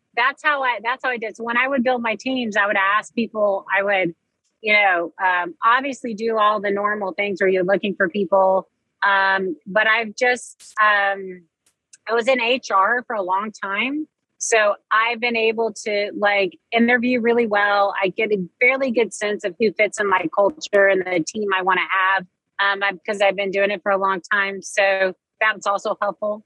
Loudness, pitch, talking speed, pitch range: -19 LUFS, 205 Hz, 200 wpm, 195-230 Hz